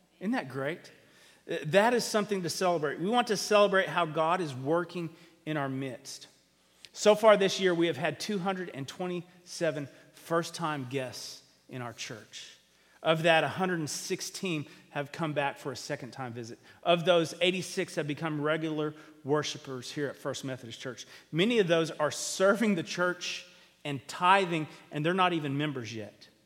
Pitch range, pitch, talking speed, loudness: 145-180 Hz, 160 Hz, 160 wpm, -30 LUFS